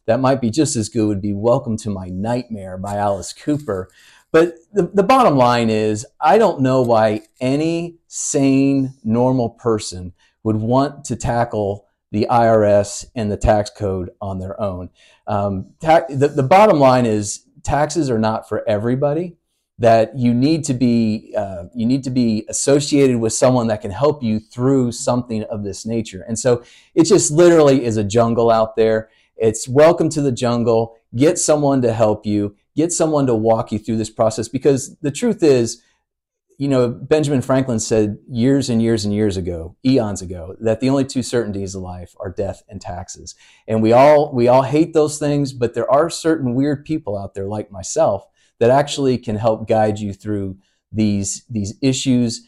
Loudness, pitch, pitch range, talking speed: -17 LUFS, 115 Hz, 105-140 Hz, 185 wpm